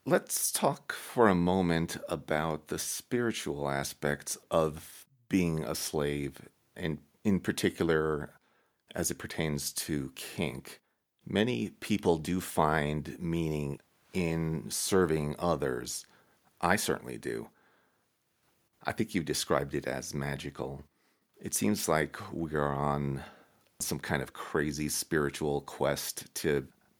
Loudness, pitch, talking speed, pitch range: -32 LUFS, 75 Hz, 115 wpm, 70-85 Hz